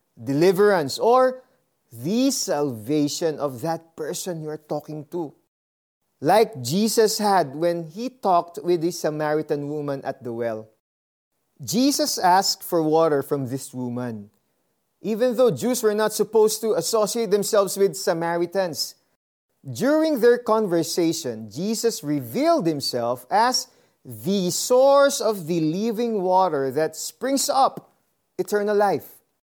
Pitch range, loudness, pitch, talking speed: 145-220 Hz, -22 LUFS, 175 Hz, 120 wpm